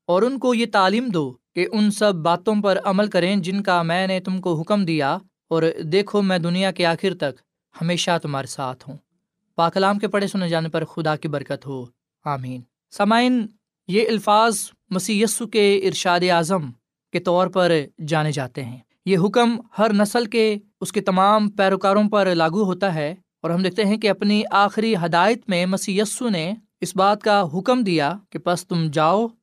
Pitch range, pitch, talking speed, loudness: 165-210 Hz, 190 Hz, 185 wpm, -20 LUFS